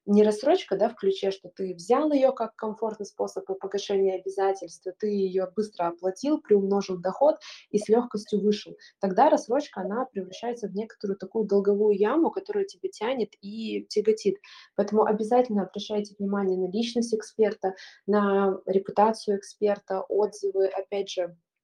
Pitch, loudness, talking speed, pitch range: 205 Hz, -27 LUFS, 140 wpm, 195-220 Hz